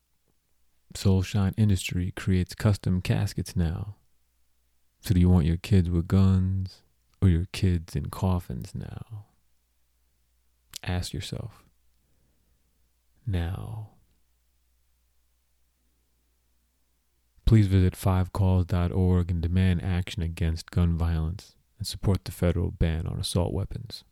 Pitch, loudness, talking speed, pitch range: 85 Hz, -27 LUFS, 100 wpm, 60-95 Hz